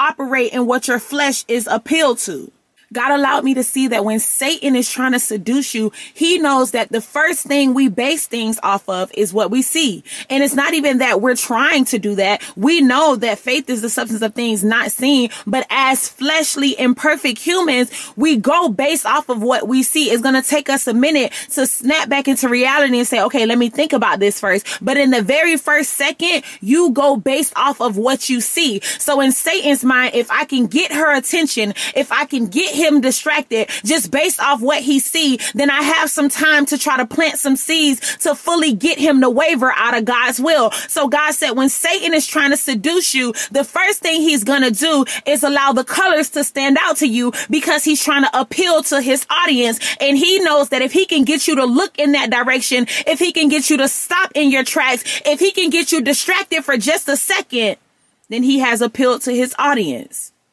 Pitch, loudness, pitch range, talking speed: 275 Hz, -14 LUFS, 250-300 Hz, 220 wpm